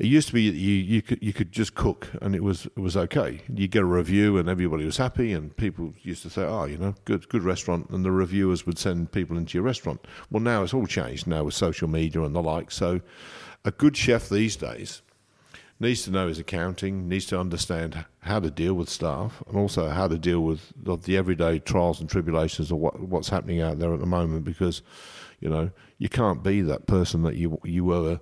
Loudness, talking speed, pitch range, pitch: -26 LUFS, 240 wpm, 85-100 Hz, 90 Hz